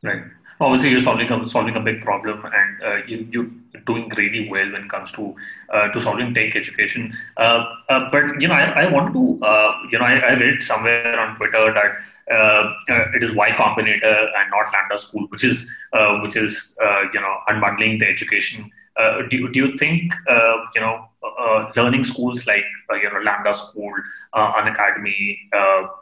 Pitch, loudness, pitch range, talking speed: 110 Hz, -17 LUFS, 105-120 Hz, 195 wpm